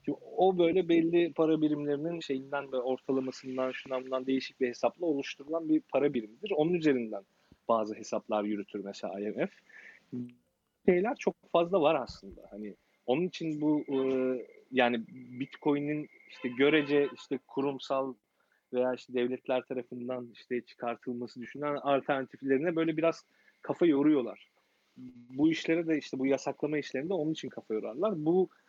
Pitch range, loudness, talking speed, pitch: 125-150 Hz, -31 LUFS, 135 wpm, 135 Hz